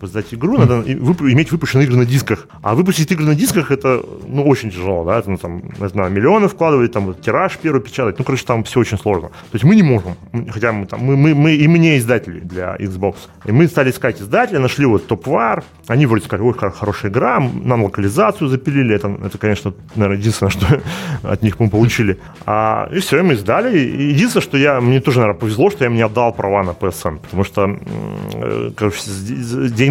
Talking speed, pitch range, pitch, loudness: 215 wpm, 100-140 Hz, 115 Hz, -15 LUFS